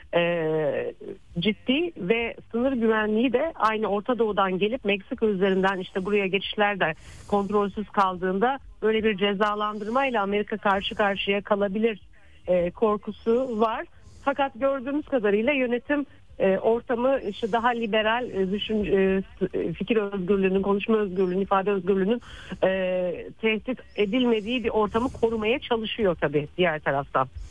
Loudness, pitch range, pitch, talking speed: -25 LUFS, 195-235 Hz, 210 Hz, 120 wpm